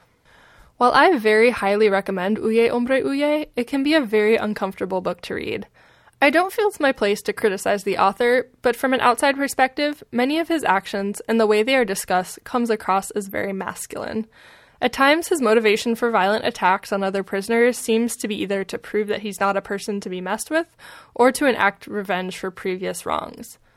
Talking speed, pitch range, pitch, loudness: 200 wpm, 200-260 Hz, 220 Hz, -20 LUFS